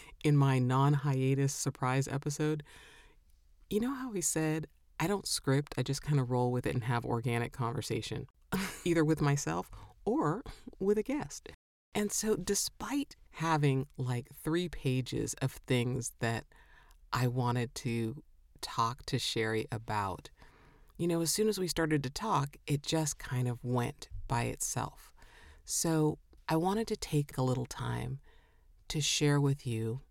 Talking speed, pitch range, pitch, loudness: 155 wpm, 120-155 Hz, 135 Hz, -33 LUFS